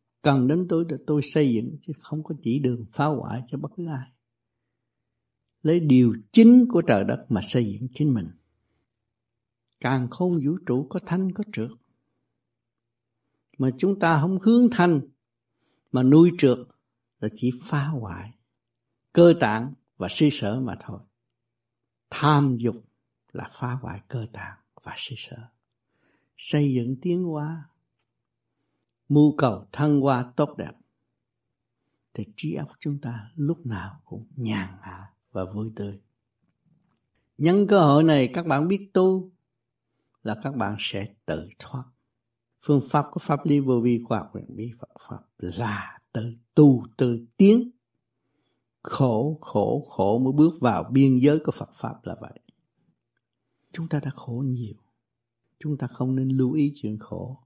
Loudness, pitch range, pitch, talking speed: -23 LUFS, 115-150 Hz, 125 Hz, 155 wpm